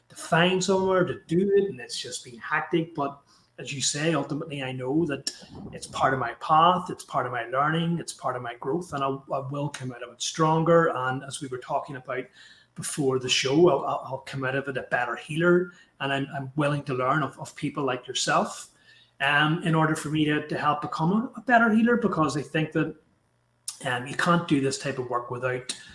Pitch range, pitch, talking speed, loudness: 135-170 Hz, 150 Hz, 225 wpm, -26 LUFS